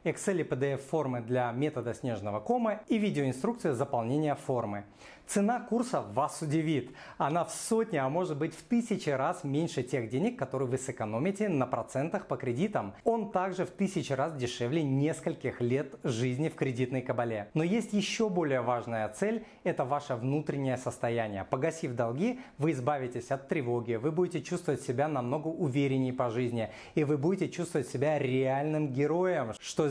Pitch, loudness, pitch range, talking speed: 145 Hz, -32 LUFS, 130-175 Hz, 160 wpm